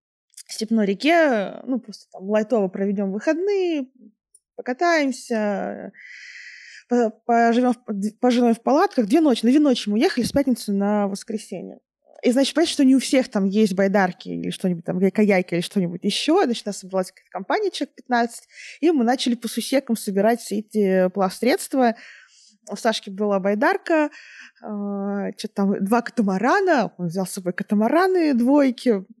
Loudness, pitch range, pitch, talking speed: -21 LUFS, 200-260 Hz, 225 Hz, 155 wpm